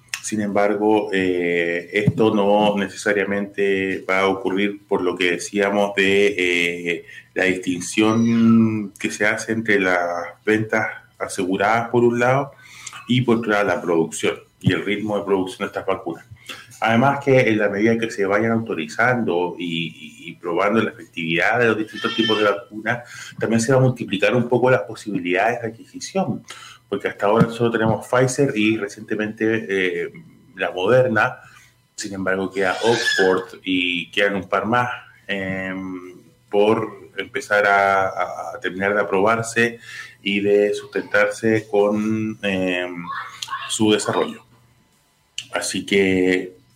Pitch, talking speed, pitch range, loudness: 105 Hz, 140 wpm, 95-115 Hz, -20 LUFS